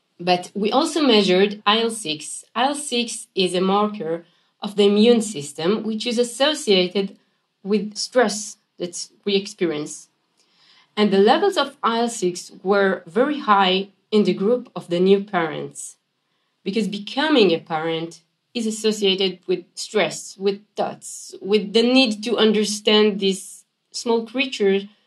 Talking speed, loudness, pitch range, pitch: 130 wpm, -20 LUFS, 185-230 Hz, 205 Hz